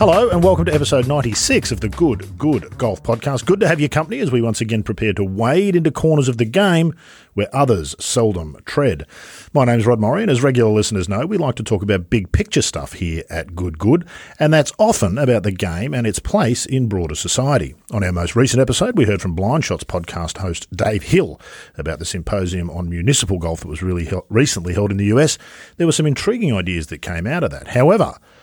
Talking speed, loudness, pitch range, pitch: 225 wpm, -18 LUFS, 90-140 Hz, 110 Hz